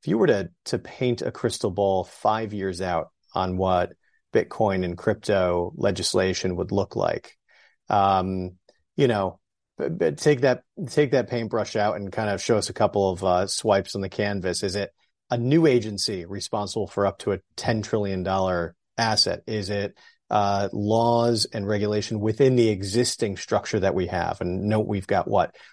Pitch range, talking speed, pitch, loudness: 95-110 Hz, 180 wpm, 100 Hz, -24 LUFS